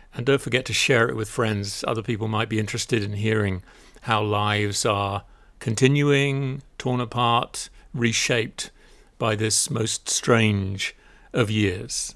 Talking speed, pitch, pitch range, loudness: 140 wpm, 110 Hz, 105-125 Hz, -23 LUFS